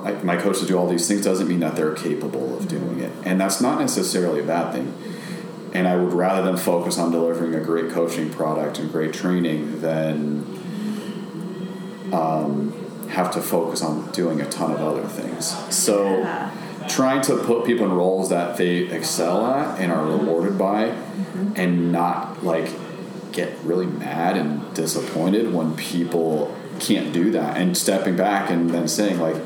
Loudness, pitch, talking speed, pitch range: -22 LUFS, 90 Hz, 175 wpm, 80-100 Hz